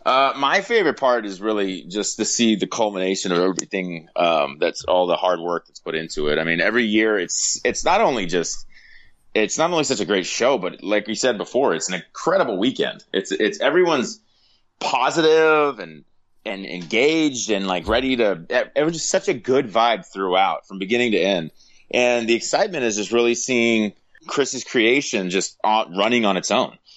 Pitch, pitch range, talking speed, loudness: 110 Hz, 95-125 Hz, 190 wpm, -20 LUFS